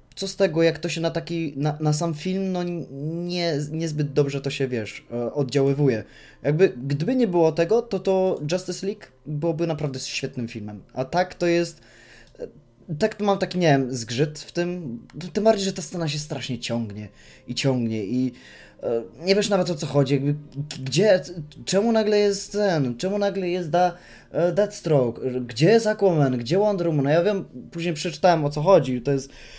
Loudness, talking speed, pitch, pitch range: -23 LUFS, 185 wpm, 160 Hz, 135-185 Hz